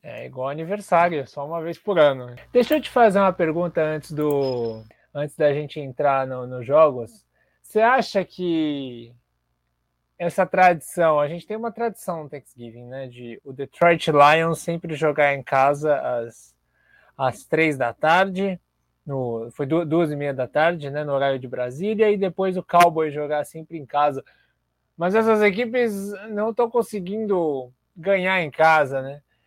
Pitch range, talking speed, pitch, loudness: 135-185 Hz, 160 wpm, 155 Hz, -21 LUFS